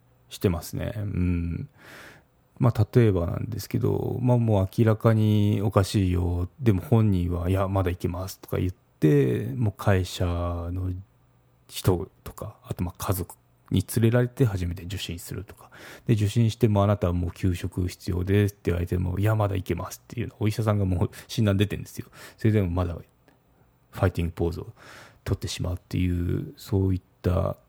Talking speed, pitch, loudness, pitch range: 355 characters per minute, 100 Hz, -26 LUFS, 90-115 Hz